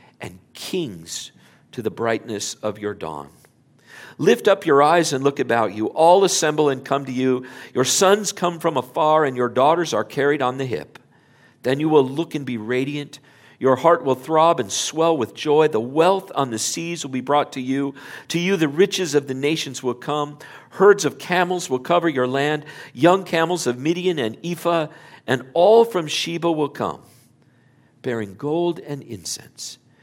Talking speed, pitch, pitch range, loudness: 185 wpm, 145 Hz, 130-170 Hz, -20 LUFS